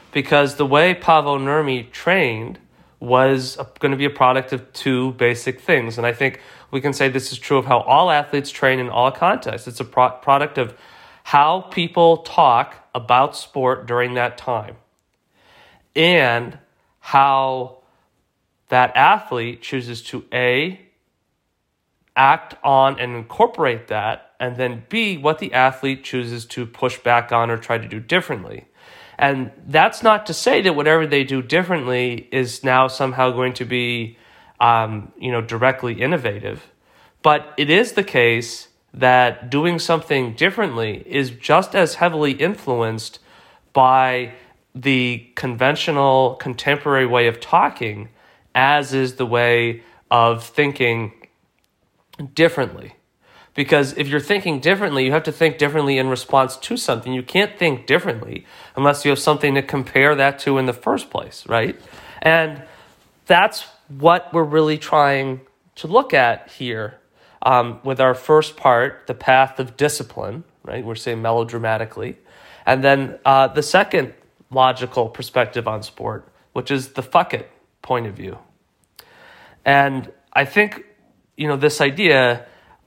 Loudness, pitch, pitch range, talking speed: -18 LUFS, 130 Hz, 125-150 Hz, 145 wpm